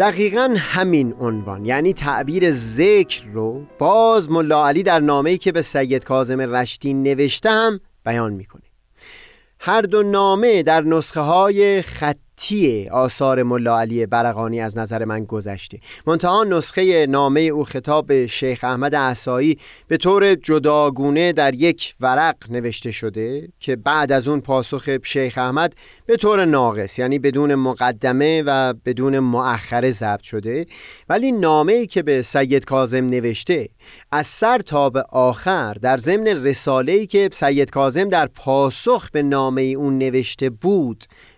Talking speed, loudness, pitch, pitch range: 140 wpm, -18 LUFS, 140 Hz, 125-170 Hz